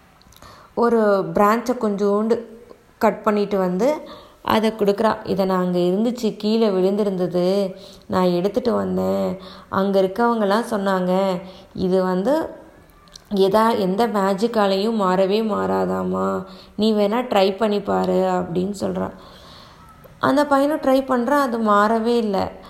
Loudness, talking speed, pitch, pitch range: -20 LUFS, 105 wpm, 205 Hz, 190-225 Hz